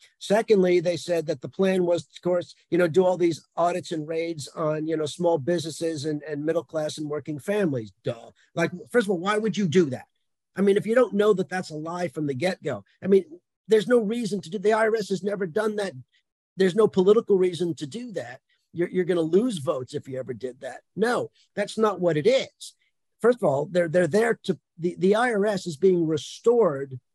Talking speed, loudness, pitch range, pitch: 225 wpm, -25 LUFS, 160-205 Hz, 180 Hz